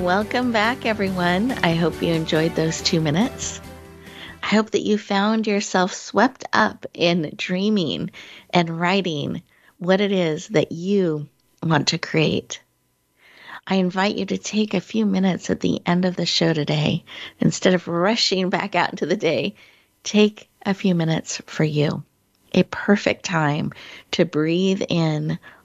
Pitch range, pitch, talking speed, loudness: 165-200 Hz, 180 Hz, 150 wpm, -21 LUFS